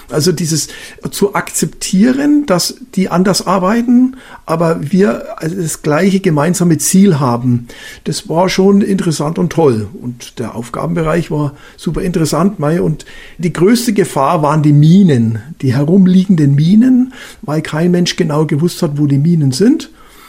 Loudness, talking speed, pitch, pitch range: -12 LUFS, 140 wpm, 170 Hz, 150-195 Hz